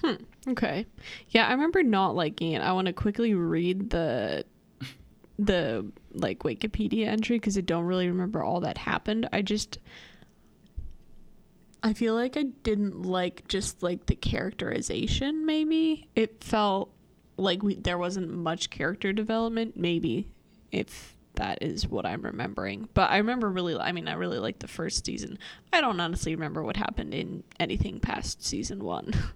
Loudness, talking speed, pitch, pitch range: -29 LUFS, 160 wpm, 200 Hz, 175-225 Hz